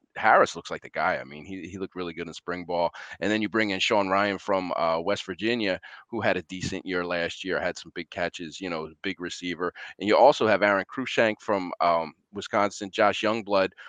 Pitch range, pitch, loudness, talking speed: 85-100 Hz, 95 Hz, -26 LUFS, 225 wpm